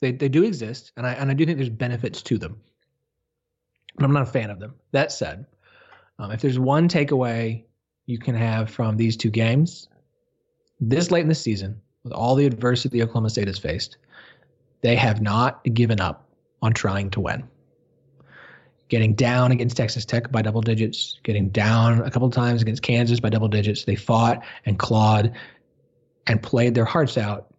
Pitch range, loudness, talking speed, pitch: 110-130 Hz, -22 LUFS, 185 wpm, 120 Hz